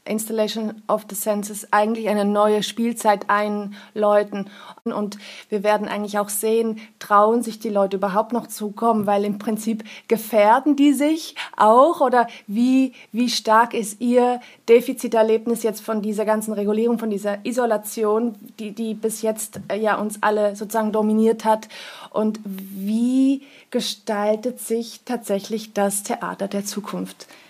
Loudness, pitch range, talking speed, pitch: -21 LUFS, 210-230 Hz, 140 wpm, 215 Hz